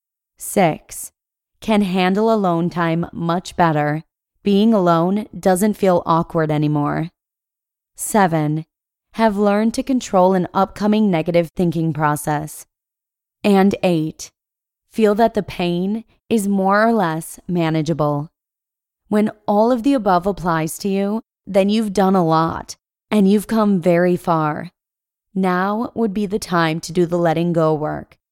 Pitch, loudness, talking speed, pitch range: 185 Hz, -18 LUFS, 135 wpm, 165-210 Hz